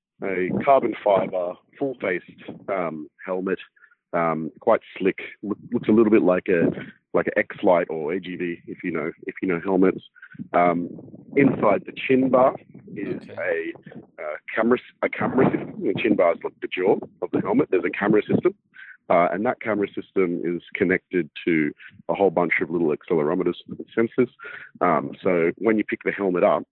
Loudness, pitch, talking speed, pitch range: -23 LUFS, 100 Hz, 175 wpm, 90-130 Hz